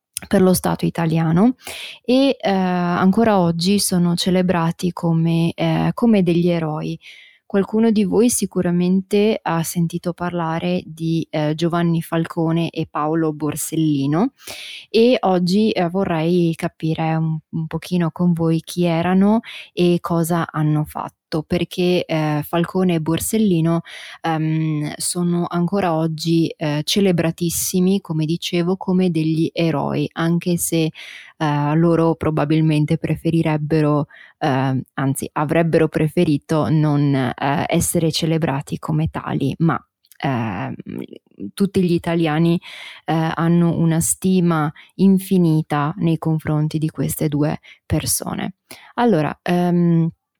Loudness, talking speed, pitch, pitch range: -19 LUFS, 115 wpm, 165 Hz, 160-180 Hz